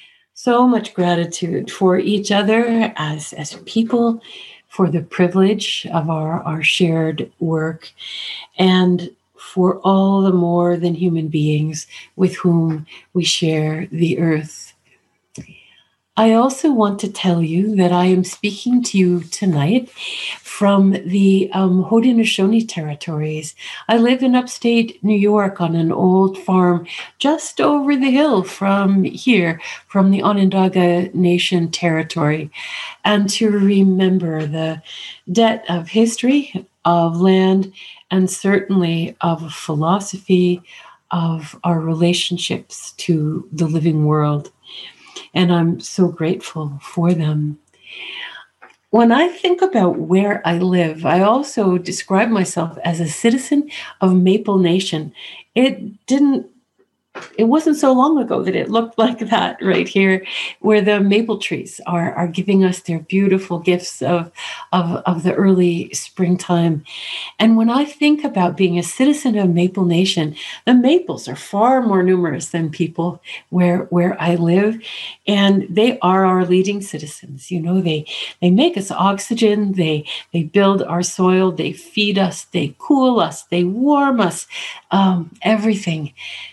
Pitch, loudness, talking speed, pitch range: 185 Hz, -17 LUFS, 135 wpm, 170-210 Hz